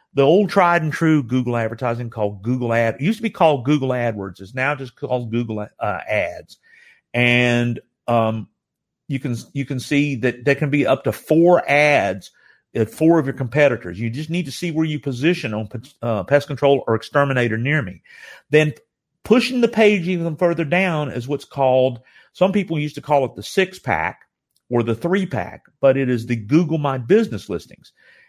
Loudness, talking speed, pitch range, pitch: -19 LUFS, 195 wpm, 120-160 Hz, 140 Hz